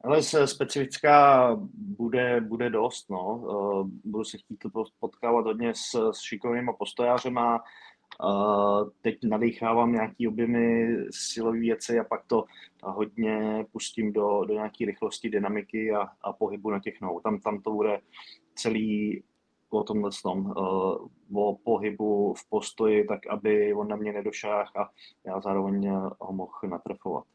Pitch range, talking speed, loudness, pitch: 105-115 Hz, 140 wpm, -28 LUFS, 110 Hz